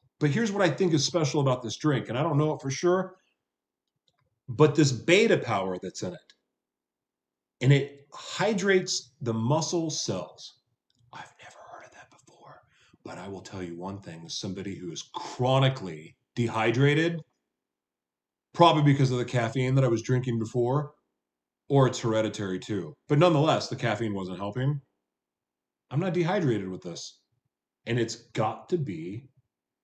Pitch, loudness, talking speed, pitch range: 130 Hz, -26 LUFS, 155 wpm, 110-155 Hz